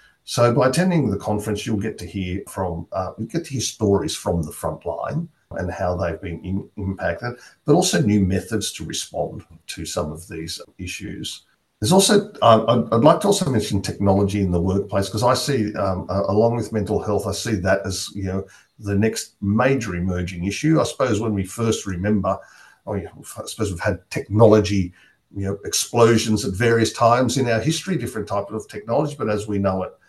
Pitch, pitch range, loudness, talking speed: 105 Hz, 95-115 Hz, -21 LUFS, 200 wpm